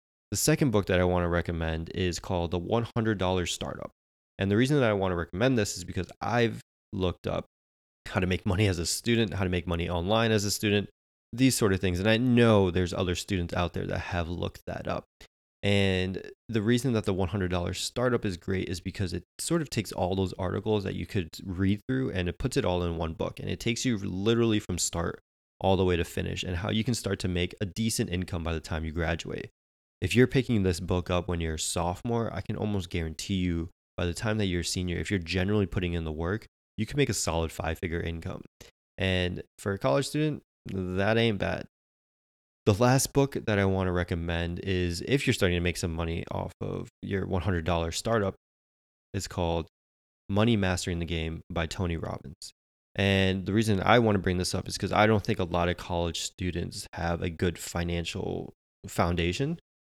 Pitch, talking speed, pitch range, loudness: 95 Hz, 215 wpm, 85-105 Hz, -29 LUFS